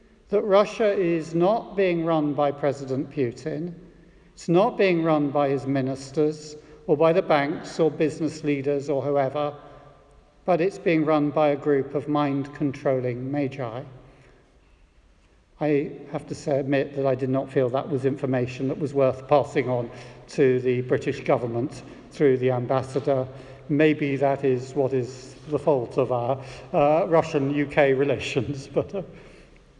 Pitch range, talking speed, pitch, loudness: 135-155 Hz, 150 wpm, 145 Hz, -24 LUFS